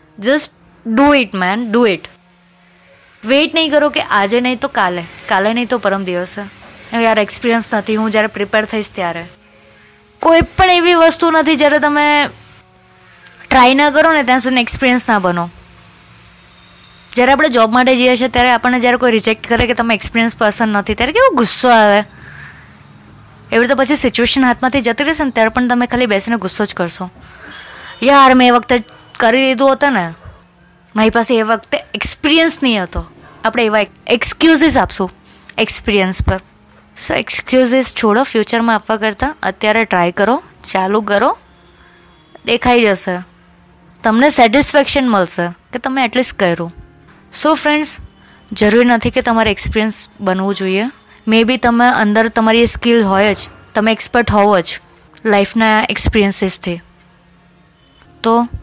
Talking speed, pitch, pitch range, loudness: 150 wpm, 230 Hz, 200-255 Hz, -12 LUFS